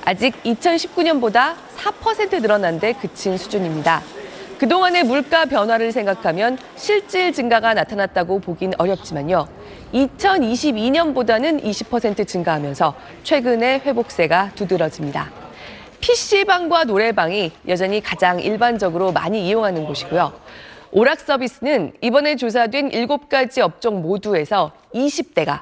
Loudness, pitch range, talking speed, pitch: -18 LUFS, 195-285 Hz, 280 characters per minute, 230 Hz